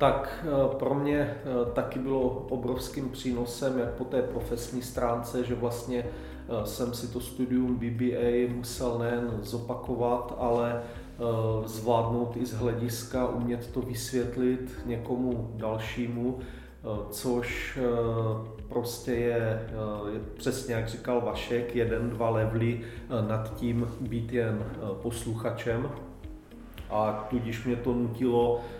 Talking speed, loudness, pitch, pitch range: 110 wpm, -31 LUFS, 120 Hz, 115-125 Hz